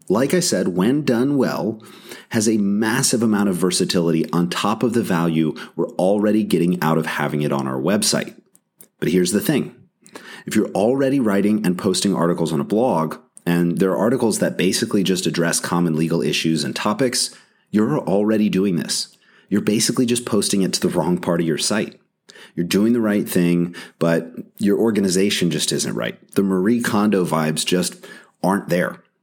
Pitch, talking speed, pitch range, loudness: 95 Hz, 180 wpm, 85-110 Hz, -19 LUFS